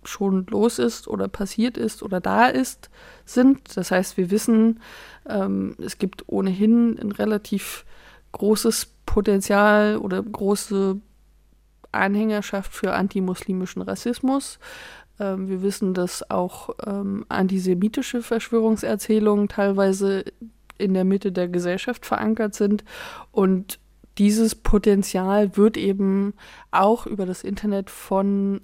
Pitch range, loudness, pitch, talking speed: 195-220 Hz, -22 LUFS, 205 Hz, 115 wpm